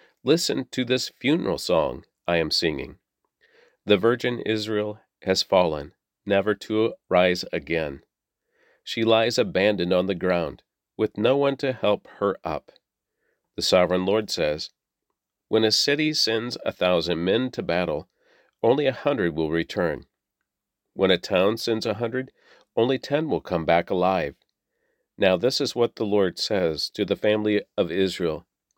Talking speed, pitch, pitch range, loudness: 150 wpm, 105 Hz, 95-120 Hz, -24 LUFS